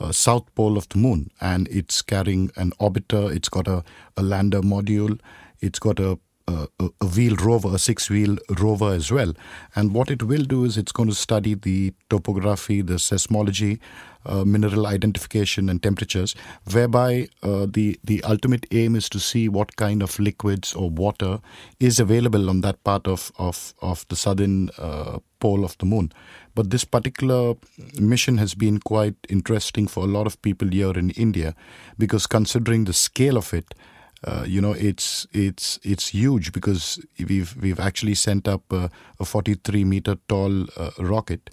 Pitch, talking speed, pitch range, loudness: 100 Hz, 175 wpm, 95-110 Hz, -22 LUFS